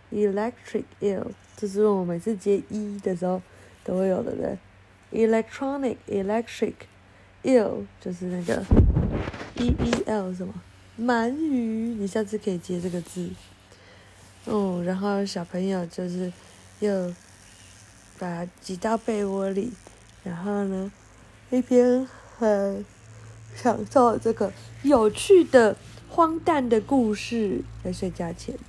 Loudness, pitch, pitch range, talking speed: -25 LUFS, 200 Hz, 180-225 Hz, 220 characters per minute